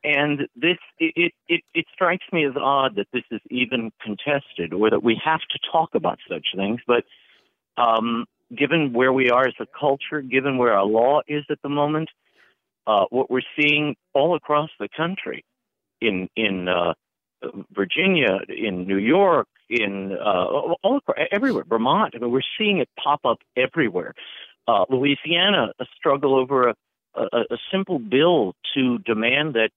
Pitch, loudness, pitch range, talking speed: 135 Hz, -21 LUFS, 115-155 Hz, 165 wpm